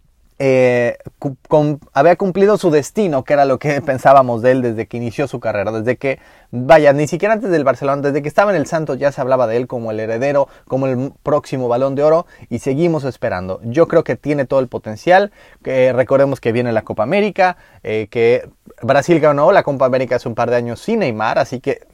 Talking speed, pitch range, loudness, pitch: 220 wpm, 120-150 Hz, -15 LUFS, 135 Hz